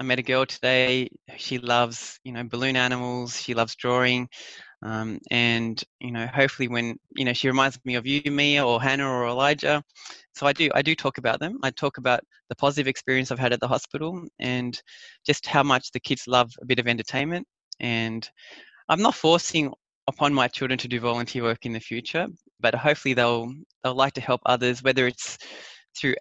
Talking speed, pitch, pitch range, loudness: 200 wpm, 125 Hz, 120-135 Hz, -24 LUFS